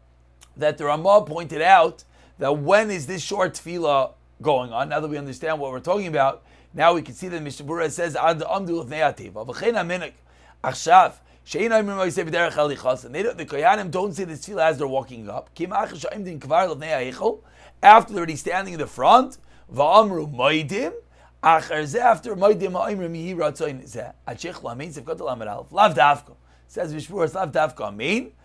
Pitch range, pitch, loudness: 140-190 Hz, 160 Hz, -21 LUFS